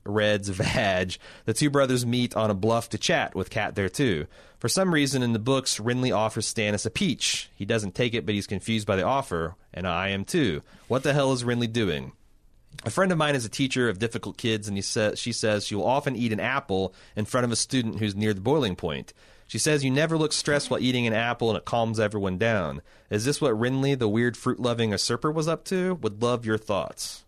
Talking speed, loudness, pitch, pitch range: 240 wpm, -26 LUFS, 115 Hz, 105-130 Hz